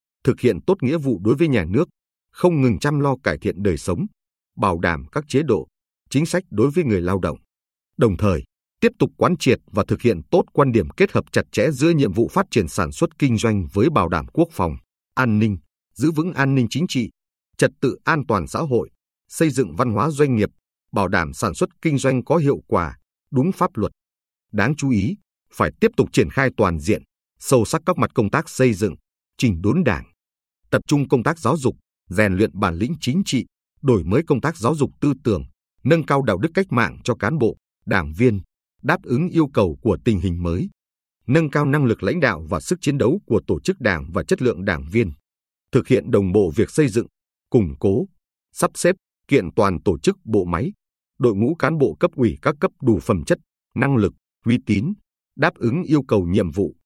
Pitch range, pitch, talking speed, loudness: 95-150 Hz, 115 Hz, 220 wpm, -20 LUFS